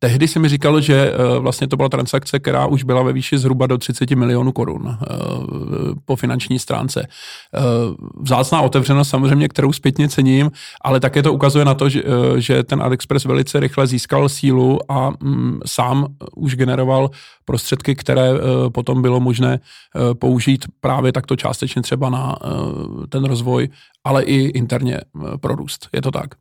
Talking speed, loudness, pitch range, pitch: 150 wpm, -17 LUFS, 130-140 Hz, 135 Hz